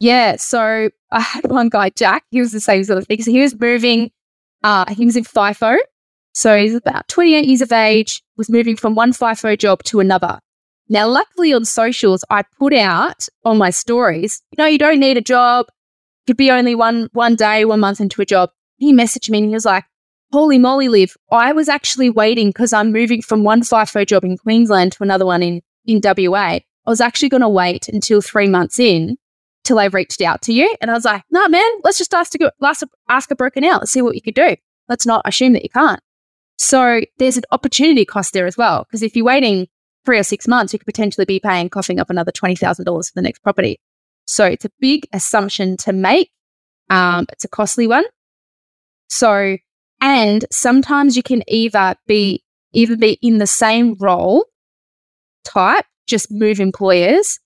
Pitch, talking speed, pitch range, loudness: 225 Hz, 210 wpm, 200-255 Hz, -14 LUFS